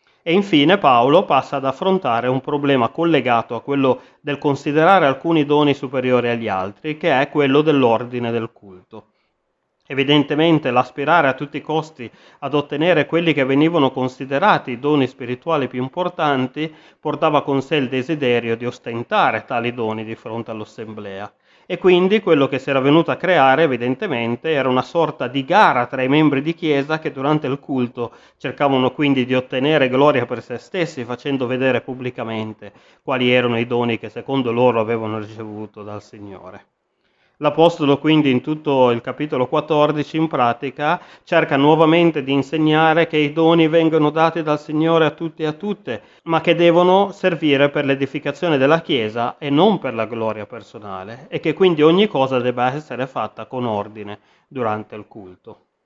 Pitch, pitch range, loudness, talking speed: 140 Hz, 120-155 Hz, -18 LUFS, 160 wpm